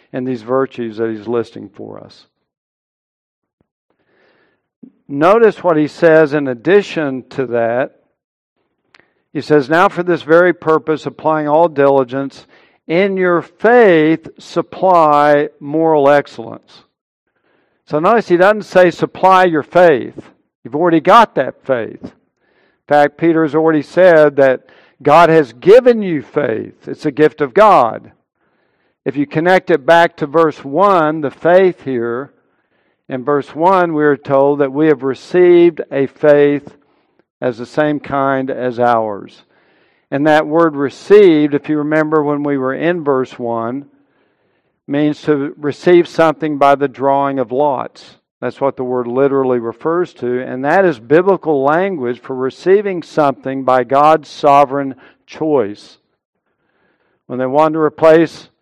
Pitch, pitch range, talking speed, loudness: 150 Hz, 135-165 Hz, 140 wpm, -13 LUFS